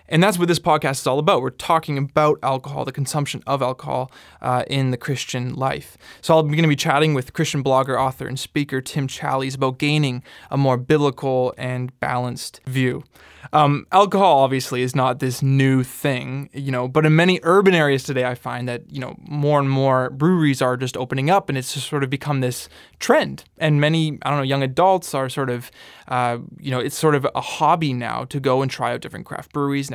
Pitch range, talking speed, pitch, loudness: 130-150 Hz, 215 wpm, 135 Hz, -20 LUFS